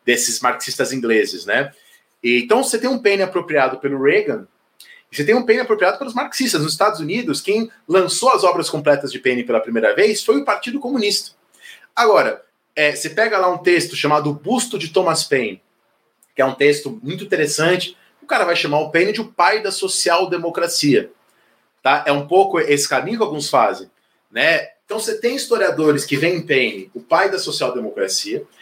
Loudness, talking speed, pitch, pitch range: -17 LUFS, 190 wpm, 180 Hz, 145-220 Hz